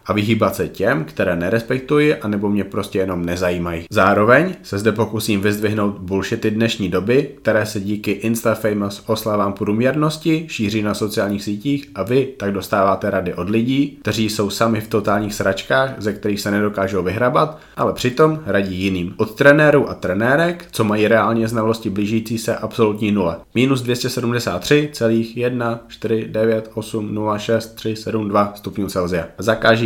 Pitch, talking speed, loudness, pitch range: 110 Hz, 135 wpm, -18 LUFS, 100-115 Hz